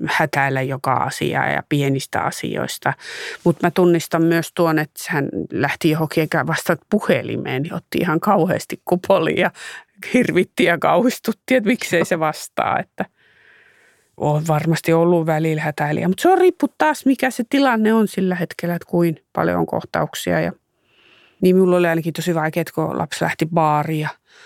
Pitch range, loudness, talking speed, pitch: 155-190 Hz, -19 LUFS, 160 wpm, 170 Hz